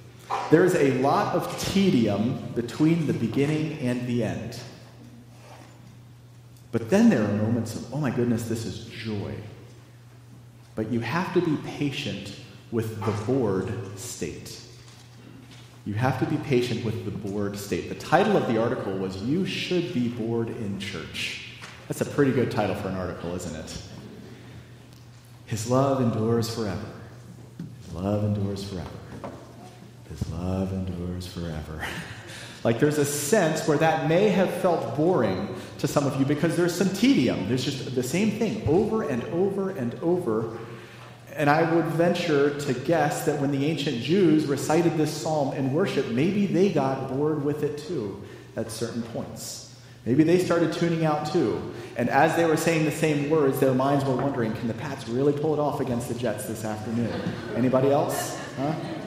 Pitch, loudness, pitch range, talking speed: 125 Hz, -25 LUFS, 115-155 Hz, 165 wpm